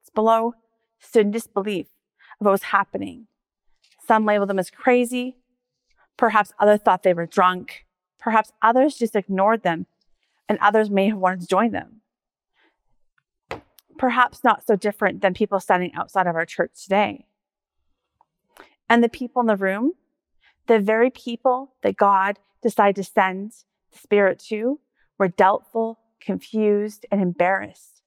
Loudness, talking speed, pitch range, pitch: -21 LUFS, 140 wpm, 195-230 Hz, 210 Hz